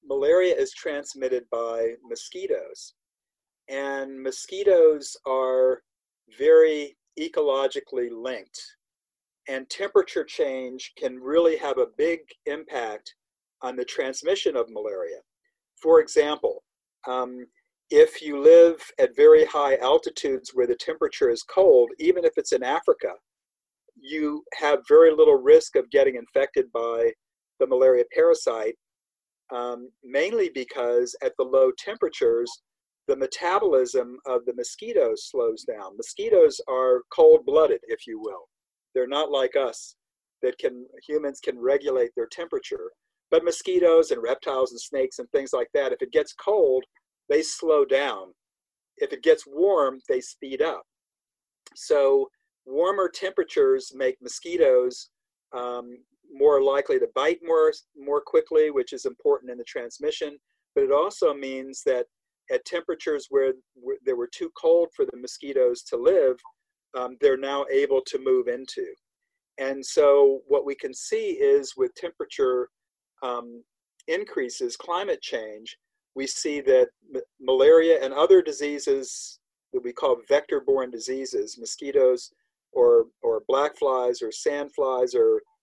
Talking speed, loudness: 135 wpm, -23 LUFS